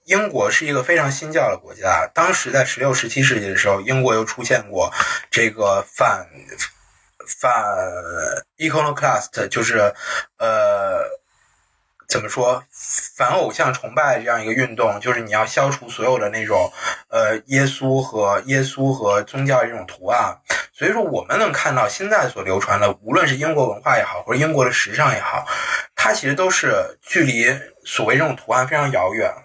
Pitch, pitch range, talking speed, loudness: 130 Hz, 115-150 Hz, 275 characters per minute, -19 LUFS